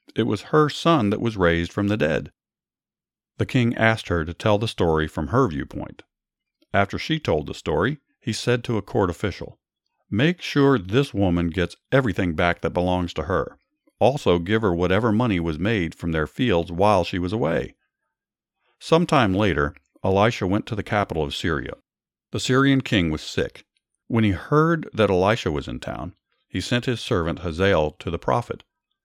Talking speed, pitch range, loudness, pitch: 180 wpm, 85-120 Hz, -22 LUFS, 100 Hz